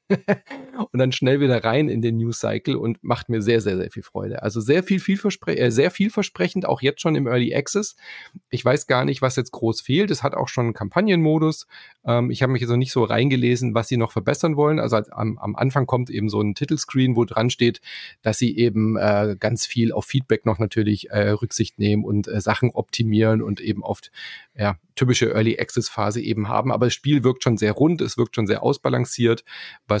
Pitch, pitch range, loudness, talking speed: 120 Hz, 110-140 Hz, -21 LUFS, 225 wpm